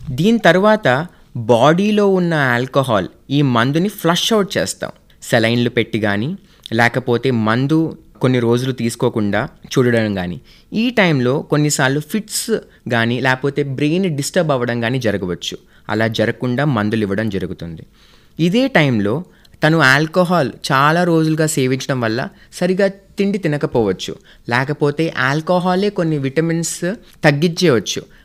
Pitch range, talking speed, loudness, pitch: 120-175 Hz, 110 wpm, -16 LUFS, 145 Hz